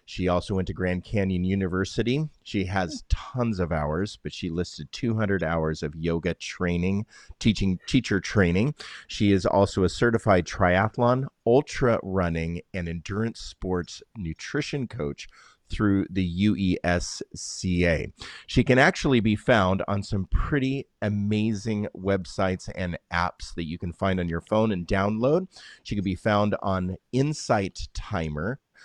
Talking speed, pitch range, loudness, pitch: 140 wpm, 90-110 Hz, -26 LUFS, 95 Hz